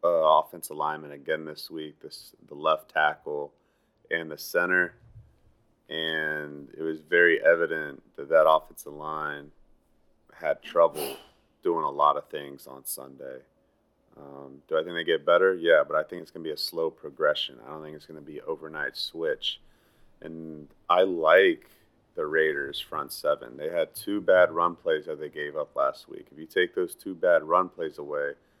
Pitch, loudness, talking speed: 80 Hz, -26 LUFS, 180 wpm